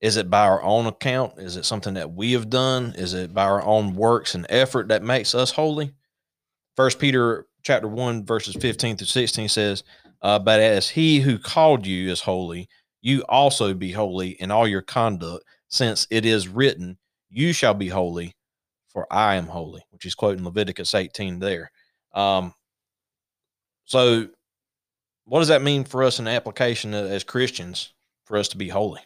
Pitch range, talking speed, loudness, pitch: 95-125 Hz, 180 wpm, -21 LUFS, 110 Hz